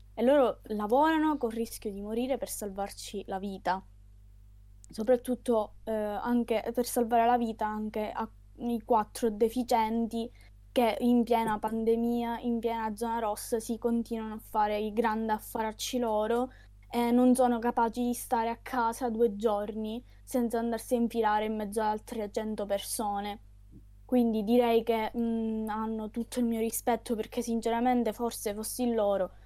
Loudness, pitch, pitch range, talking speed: -30 LUFS, 230 Hz, 215-235 Hz, 150 wpm